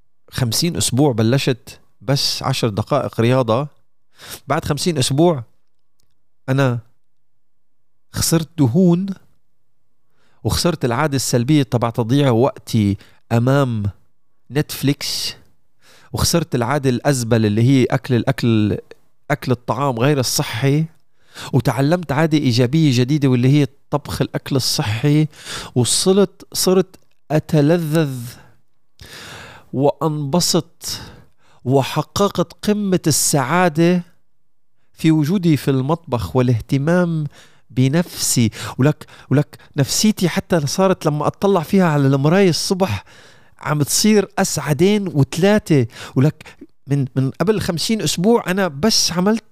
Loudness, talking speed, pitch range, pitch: -17 LUFS, 95 wpm, 125-165 Hz, 140 Hz